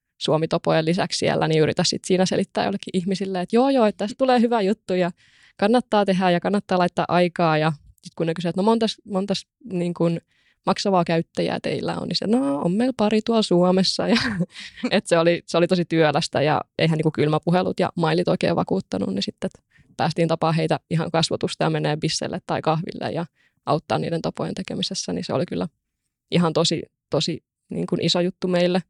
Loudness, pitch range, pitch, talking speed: -22 LUFS, 165-200 Hz, 180 Hz, 195 wpm